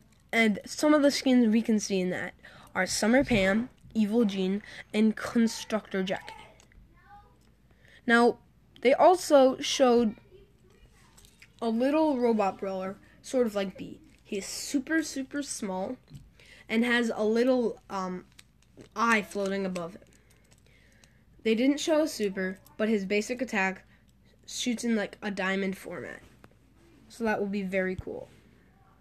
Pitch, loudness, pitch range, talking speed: 220 Hz, -28 LUFS, 195-250 Hz, 135 wpm